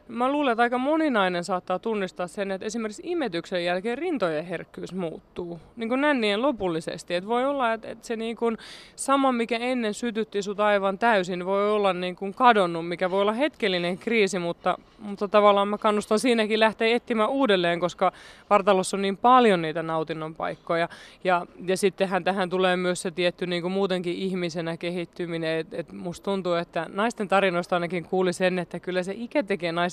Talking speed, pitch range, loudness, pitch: 175 wpm, 175-225 Hz, -25 LUFS, 195 Hz